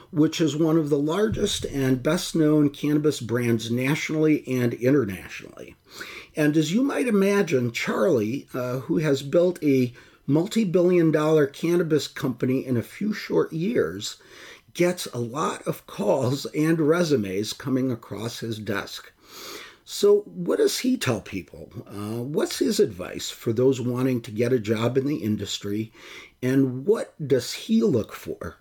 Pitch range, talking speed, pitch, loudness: 120-160 Hz, 150 wpm, 135 Hz, -24 LUFS